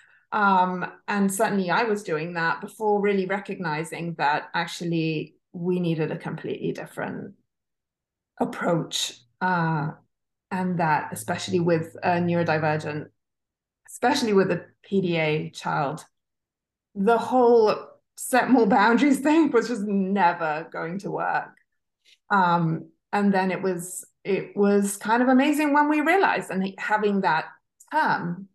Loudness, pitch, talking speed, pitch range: -24 LUFS, 190 Hz, 125 wpm, 170-220 Hz